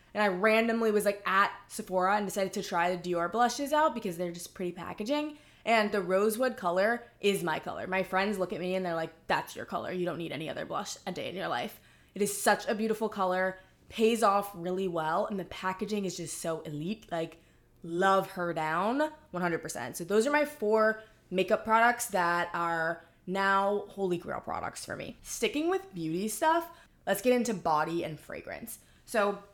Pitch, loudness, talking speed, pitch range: 195 Hz, -30 LUFS, 195 wpm, 175-220 Hz